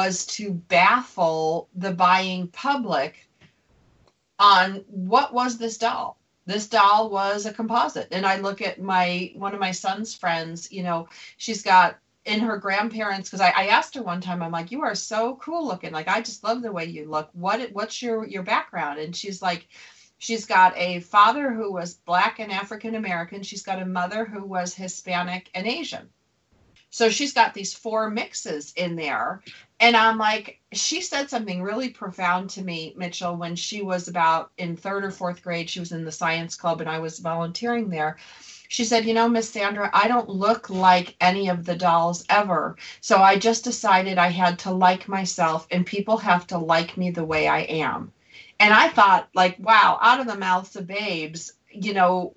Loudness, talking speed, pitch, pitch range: -22 LUFS, 190 wpm, 195 Hz, 175-220 Hz